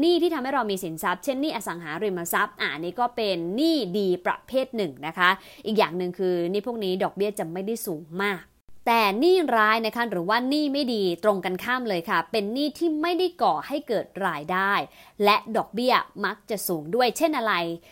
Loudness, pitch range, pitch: -25 LUFS, 185-250 Hz, 210 Hz